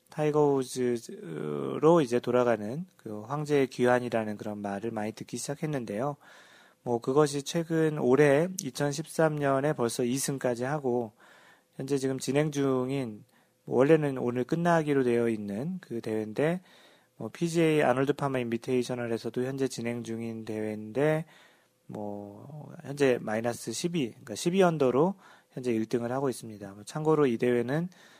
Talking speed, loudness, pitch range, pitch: 290 characters per minute, -29 LUFS, 115-150 Hz, 130 Hz